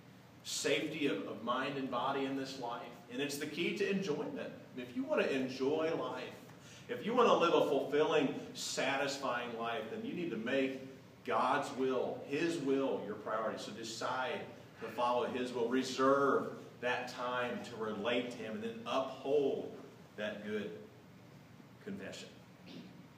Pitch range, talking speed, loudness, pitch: 125-150 Hz, 155 wpm, -36 LUFS, 135 Hz